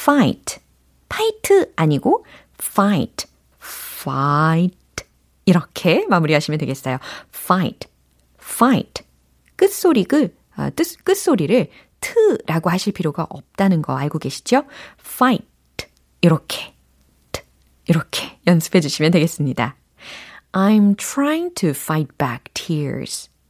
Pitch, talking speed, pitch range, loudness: 165 Hz, 300 characters per minute, 140-210 Hz, -19 LUFS